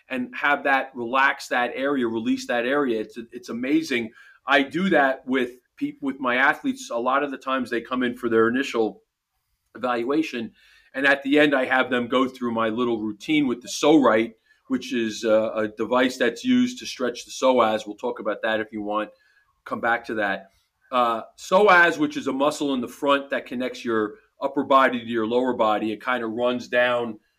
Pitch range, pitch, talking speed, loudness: 115-140 Hz, 125 Hz, 200 wpm, -23 LUFS